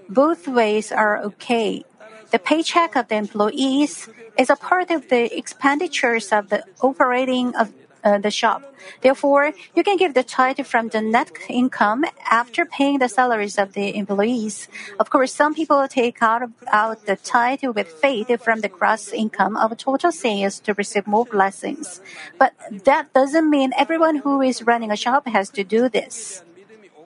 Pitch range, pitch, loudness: 215-275 Hz, 240 Hz, -19 LUFS